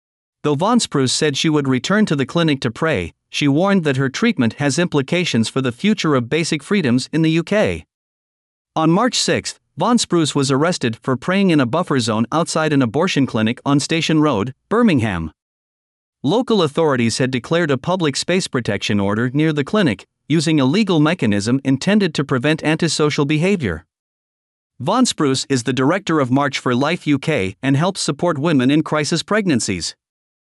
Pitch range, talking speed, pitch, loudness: 130-170 Hz, 170 wpm, 150 Hz, -17 LUFS